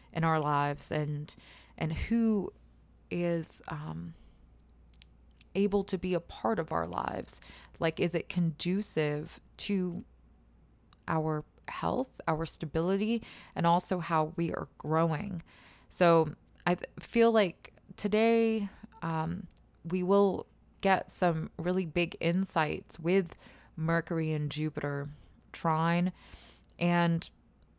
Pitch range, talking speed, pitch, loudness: 150-185 Hz, 110 wpm, 165 Hz, -31 LUFS